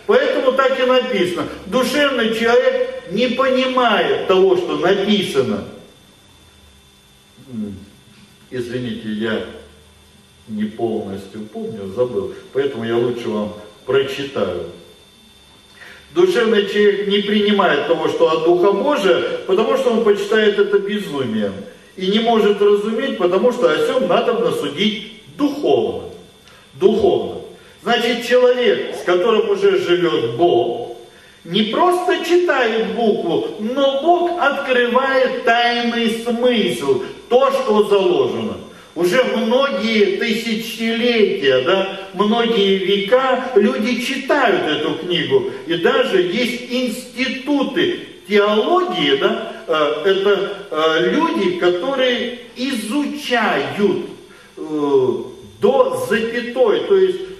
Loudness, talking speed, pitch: -17 LUFS, 95 wpm, 235 Hz